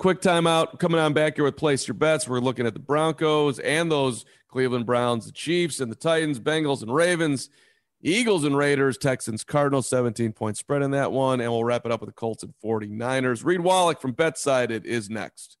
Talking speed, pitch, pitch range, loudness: 210 wpm, 140 Hz, 120-155 Hz, -24 LUFS